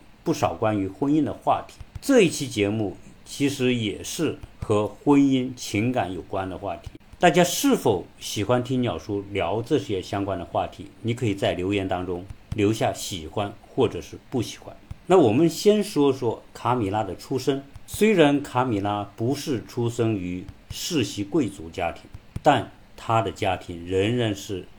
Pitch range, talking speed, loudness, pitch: 100-135 Hz, 240 characters per minute, -24 LUFS, 110 Hz